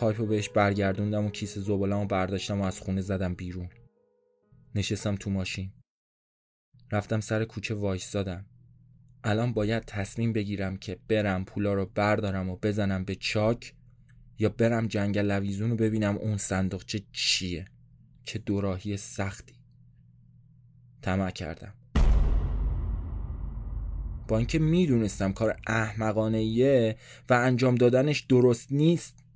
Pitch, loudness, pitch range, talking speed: 105 Hz, -28 LUFS, 95-120 Hz, 120 wpm